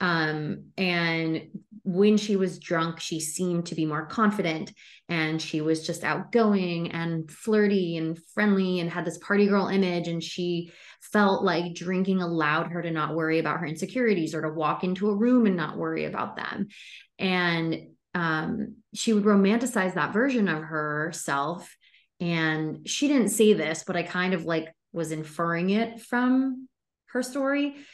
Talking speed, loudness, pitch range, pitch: 165 wpm, -26 LUFS, 160-205 Hz, 175 Hz